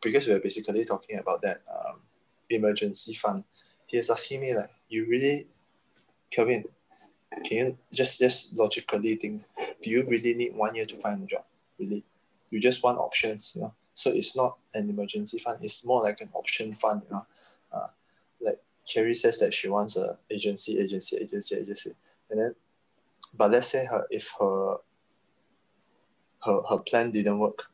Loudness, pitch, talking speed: -29 LUFS, 120 Hz, 170 wpm